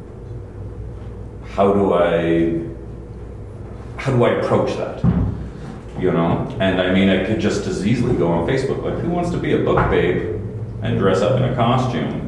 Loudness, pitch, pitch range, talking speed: -19 LUFS, 105 Hz, 95-115 Hz, 170 wpm